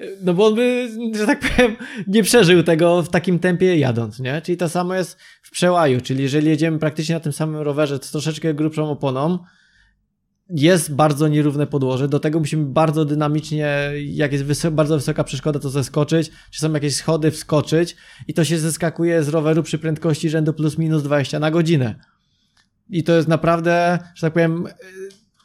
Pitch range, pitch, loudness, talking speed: 150-175 Hz, 160 Hz, -19 LUFS, 180 wpm